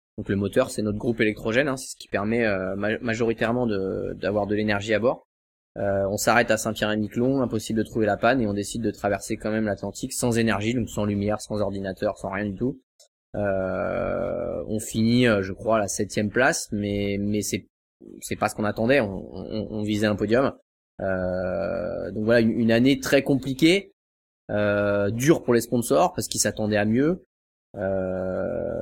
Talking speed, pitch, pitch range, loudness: 190 wpm, 105 Hz, 100-120 Hz, -24 LUFS